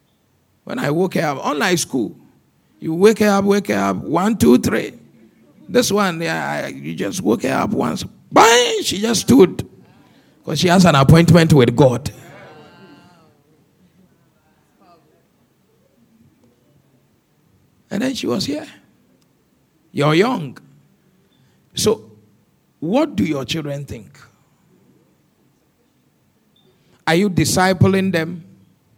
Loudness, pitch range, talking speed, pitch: -16 LUFS, 160-205 Hz, 110 wpm, 180 Hz